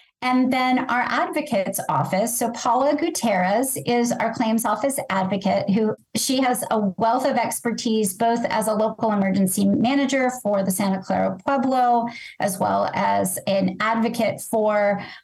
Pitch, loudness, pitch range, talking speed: 225 Hz, -21 LUFS, 200-250 Hz, 145 wpm